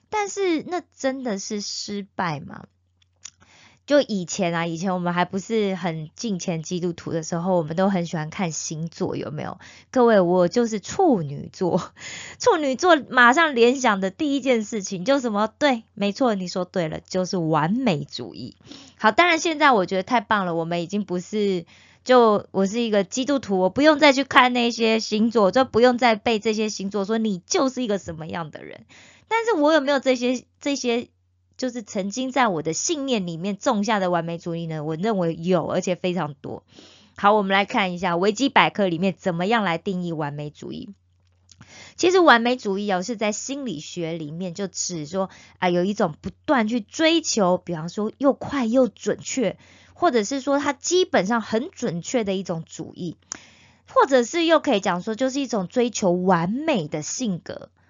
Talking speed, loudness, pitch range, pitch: 275 characters per minute, -22 LUFS, 180-250 Hz, 205 Hz